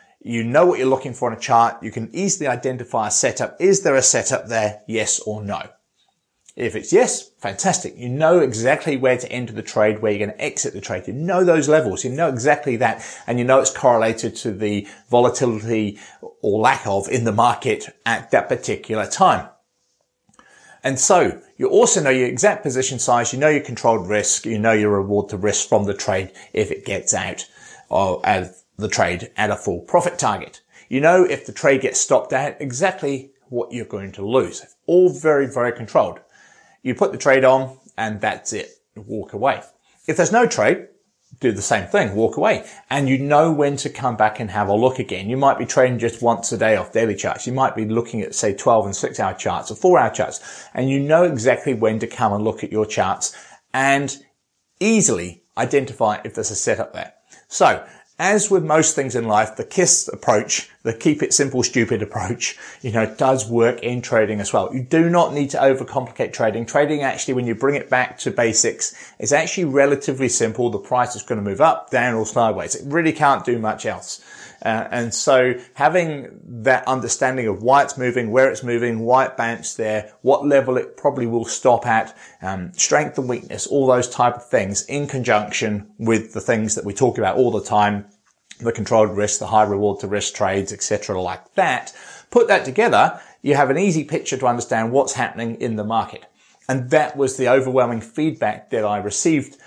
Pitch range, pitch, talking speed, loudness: 110-140 Hz, 125 Hz, 205 wpm, -19 LUFS